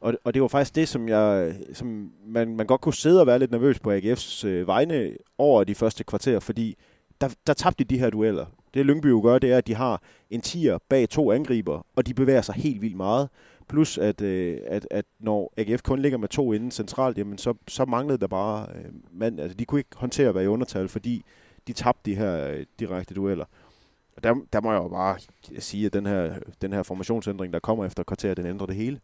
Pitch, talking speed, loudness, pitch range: 110 Hz, 225 wpm, -25 LUFS, 100-125 Hz